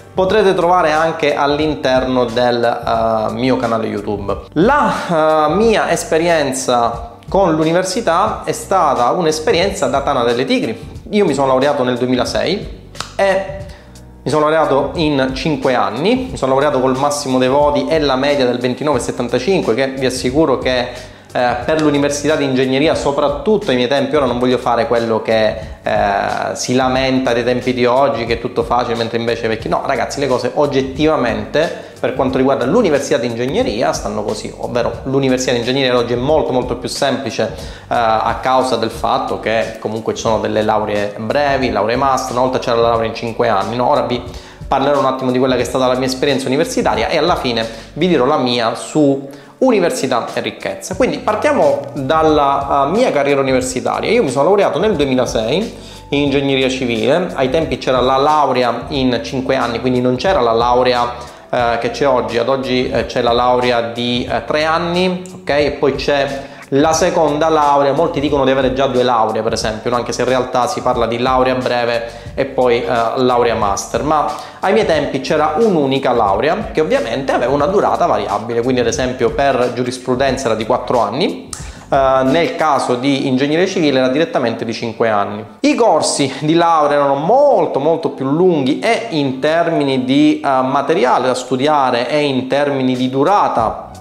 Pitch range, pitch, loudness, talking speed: 120-150 Hz, 130 Hz, -15 LUFS, 175 wpm